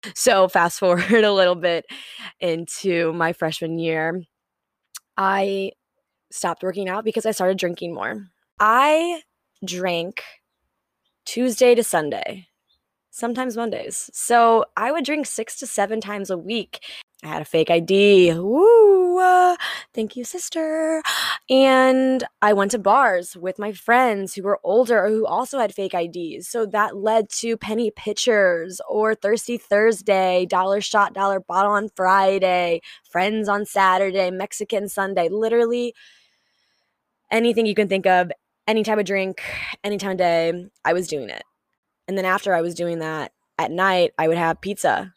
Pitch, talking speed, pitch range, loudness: 200 Hz, 150 wpm, 180-230 Hz, -20 LUFS